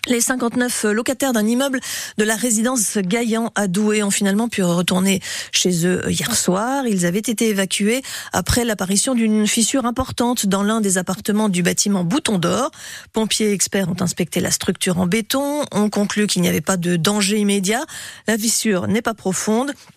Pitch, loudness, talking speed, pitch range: 210 Hz, -18 LUFS, 175 wpm, 195-235 Hz